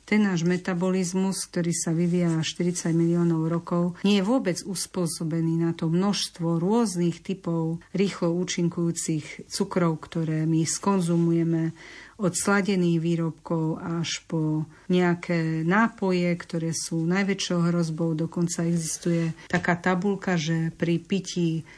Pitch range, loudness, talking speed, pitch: 165-185 Hz, -25 LUFS, 115 wpm, 170 Hz